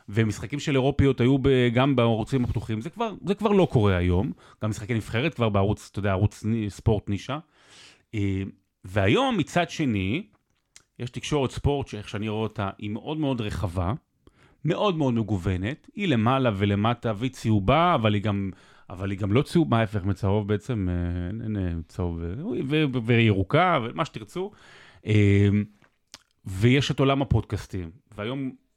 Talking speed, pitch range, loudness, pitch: 140 wpm, 100-135 Hz, -25 LUFS, 110 Hz